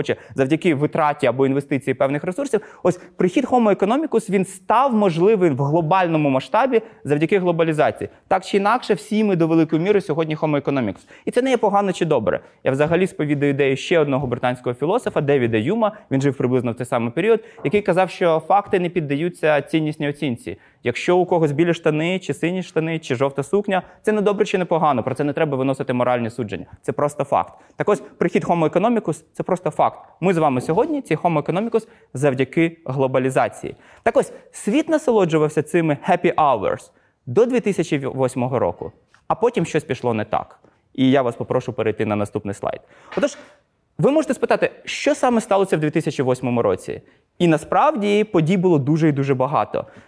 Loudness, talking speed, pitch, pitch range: -20 LUFS, 175 wpm, 165 Hz, 140-200 Hz